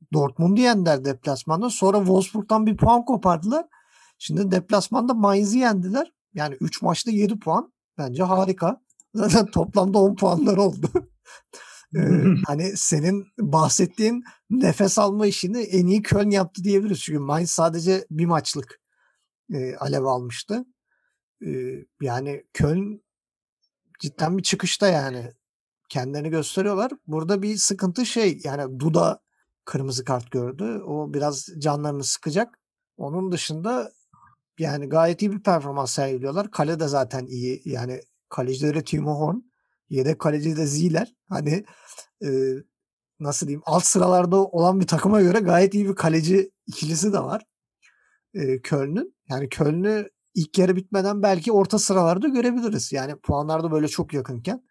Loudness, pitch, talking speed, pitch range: -22 LUFS, 180 Hz, 130 wpm, 150-205 Hz